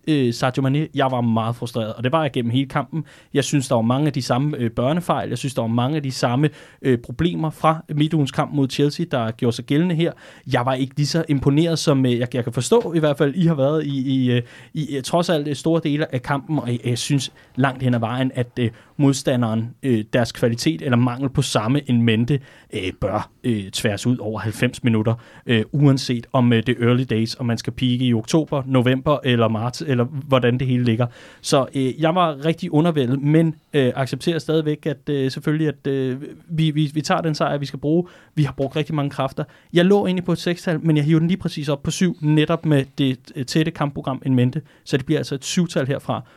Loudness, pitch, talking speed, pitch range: -21 LUFS, 140 Hz, 230 wpm, 125-155 Hz